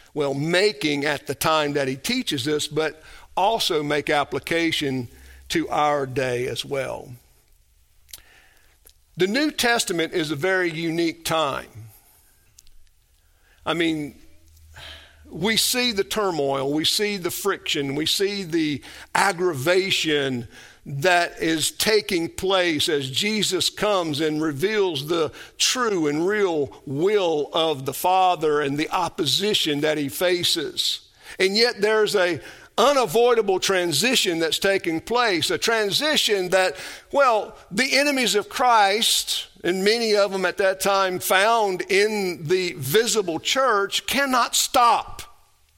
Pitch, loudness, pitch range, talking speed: 175 Hz, -21 LUFS, 145-210 Hz, 125 wpm